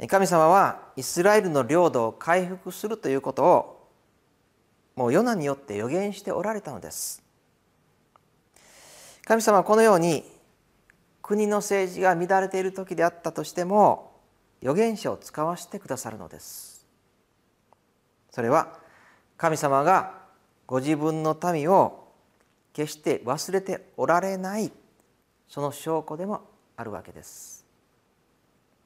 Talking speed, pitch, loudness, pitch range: 245 characters per minute, 175 Hz, -24 LUFS, 145-195 Hz